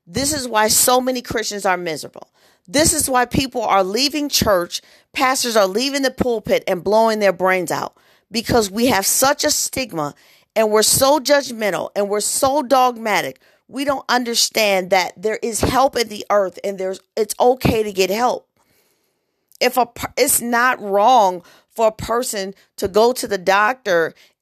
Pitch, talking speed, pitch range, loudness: 225 Hz, 170 wpm, 200-260 Hz, -17 LUFS